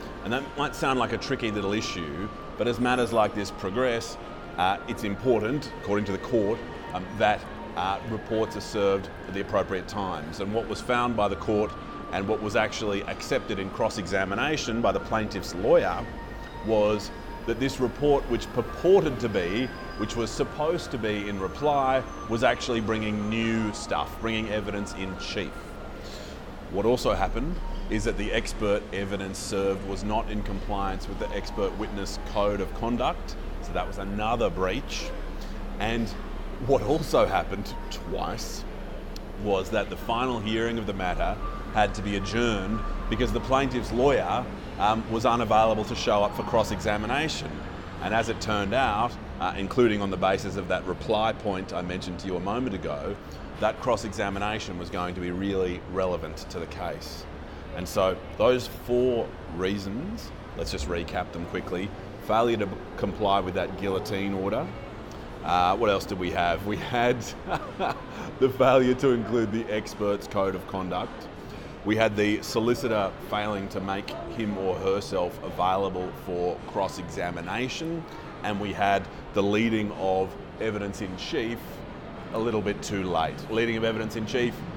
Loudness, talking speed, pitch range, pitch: -28 LUFS, 165 wpm, 95-115 Hz, 105 Hz